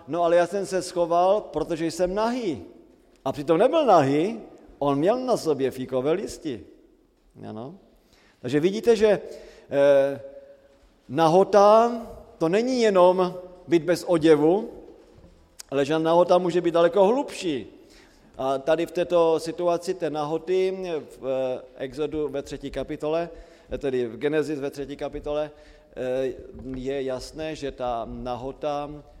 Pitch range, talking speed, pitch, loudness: 140-180 Hz, 120 wpm, 160 Hz, -24 LUFS